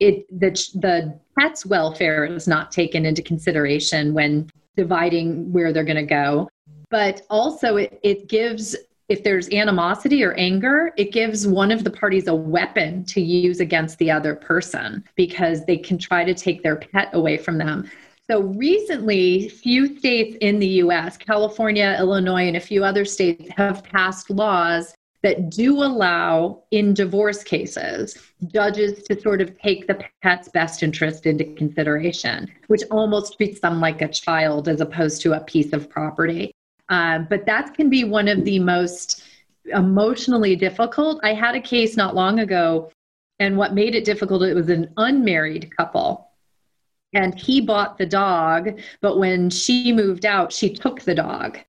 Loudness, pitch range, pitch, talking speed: -20 LUFS, 170-210 Hz, 190 Hz, 165 wpm